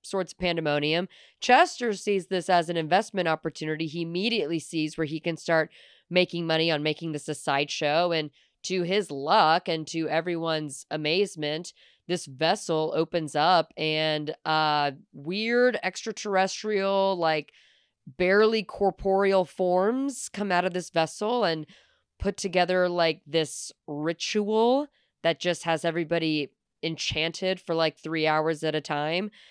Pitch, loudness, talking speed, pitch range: 170 Hz, -26 LUFS, 135 wpm, 155-190 Hz